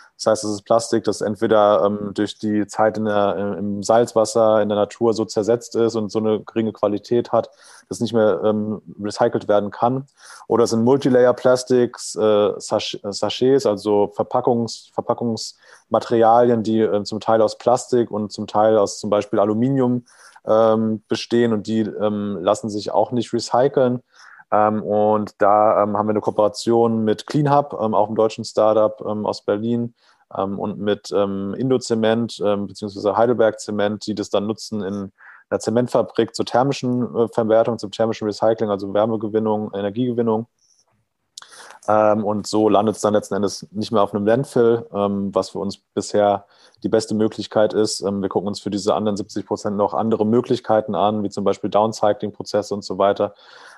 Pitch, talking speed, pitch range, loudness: 110 Hz, 170 wpm, 105-115 Hz, -20 LUFS